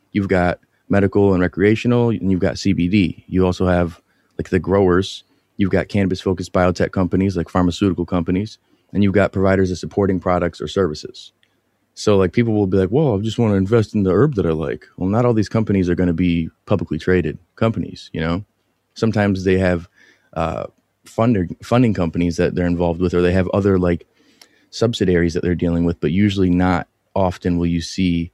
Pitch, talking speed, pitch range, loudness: 95 Hz, 195 wpm, 90-100 Hz, -18 LUFS